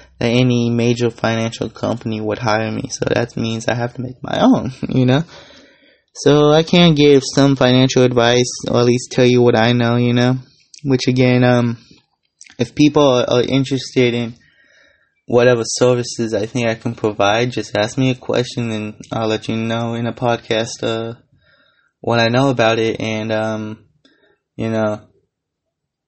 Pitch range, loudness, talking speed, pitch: 115-130 Hz, -16 LUFS, 175 wpm, 120 Hz